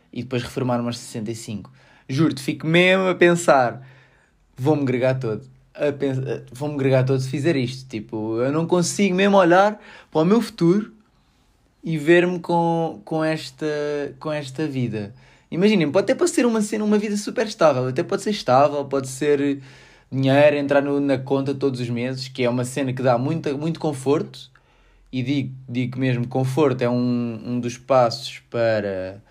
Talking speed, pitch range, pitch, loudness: 170 wpm, 125-165 Hz, 140 Hz, -21 LUFS